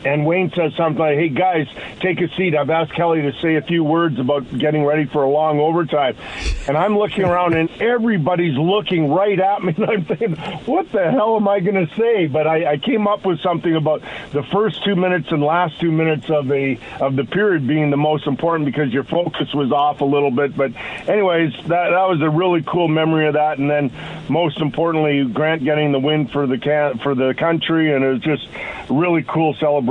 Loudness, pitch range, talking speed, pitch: -18 LUFS, 145-175 Hz, 225 wpm, 160 Hz